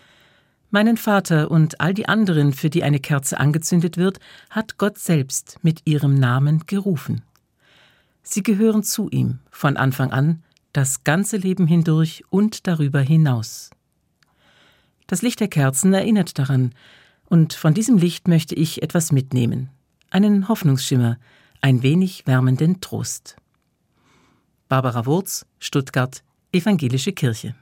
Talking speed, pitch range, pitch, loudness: 125 wpm, 135-190 Hz, 160 Hz, -19 LUFS